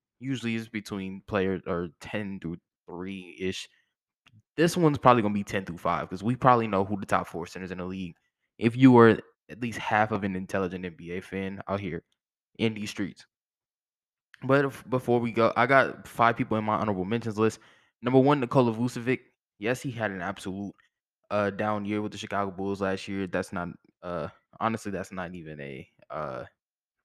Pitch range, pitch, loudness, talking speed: 95-115 Hz, 105 Hz, -27 LUFS, 190 wpm